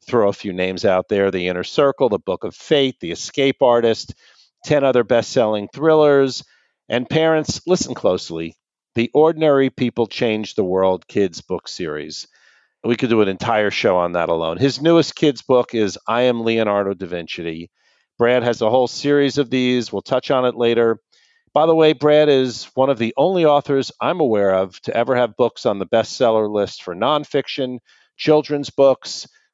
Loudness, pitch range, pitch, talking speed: -18 LUFS, 105-145 Hz, 125 Hz, 185 wpm